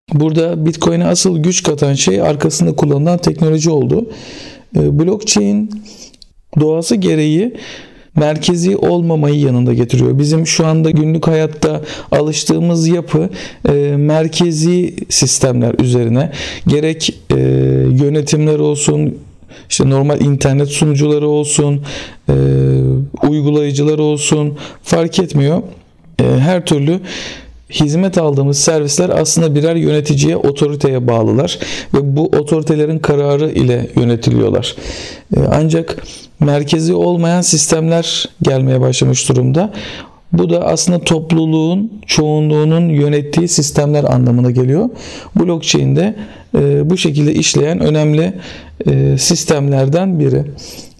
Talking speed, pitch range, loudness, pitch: 100 wpm, 140-165 Hz, -13 LUFS, 150 Hz